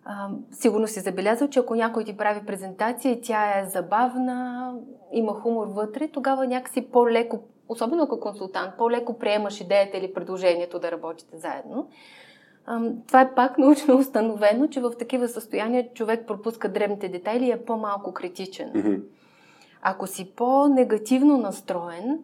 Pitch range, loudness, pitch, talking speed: 200-250 Hz, -24 LUFS, 230 Hz, 145 wpm